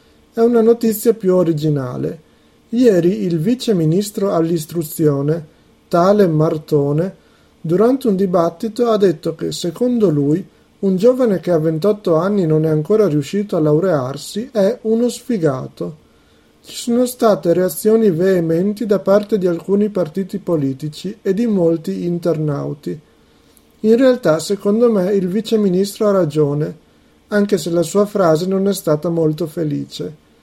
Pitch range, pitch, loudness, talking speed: 160-210 Hz, 185 Hz, -16 LUFS, 130 wpm